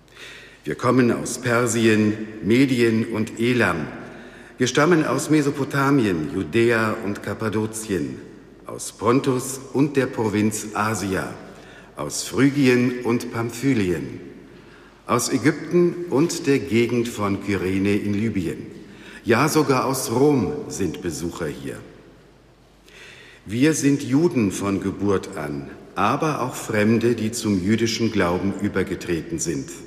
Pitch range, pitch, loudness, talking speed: 100-135 Hz, 115 Hz, -21 LUFS, 110 wpm